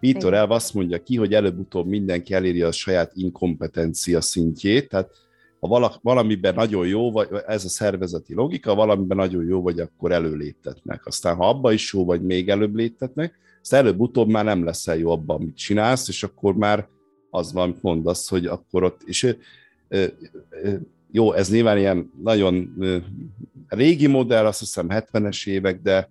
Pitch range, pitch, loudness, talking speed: 90-110 Hz, 95 Hz, -21 LUFS, 165 wpm